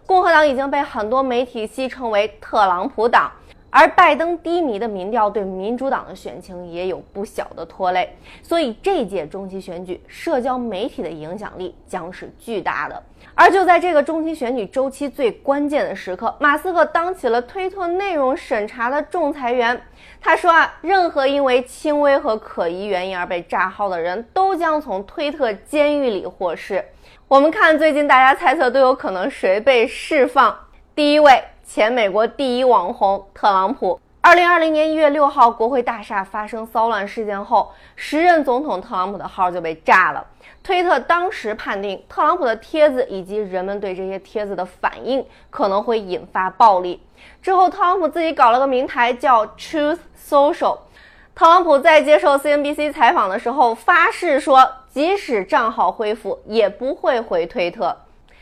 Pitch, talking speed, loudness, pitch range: 260 Hz, 280 characters per minute, -17 LUFS, 210-305 Hz